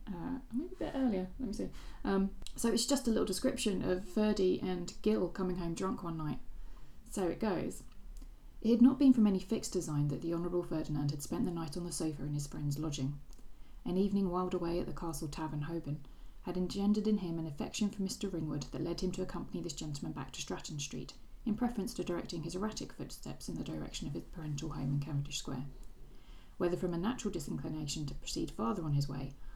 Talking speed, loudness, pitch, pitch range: 215 wpm, -36 LUFS, 175 Hz, 150-205 Hz